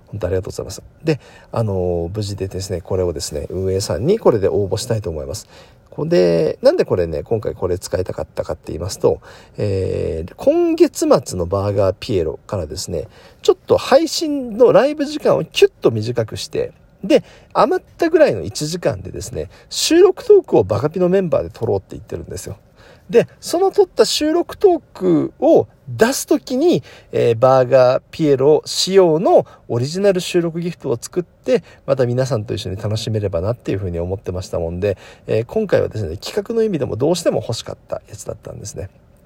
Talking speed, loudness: 400 characters per minute, -18 LUFS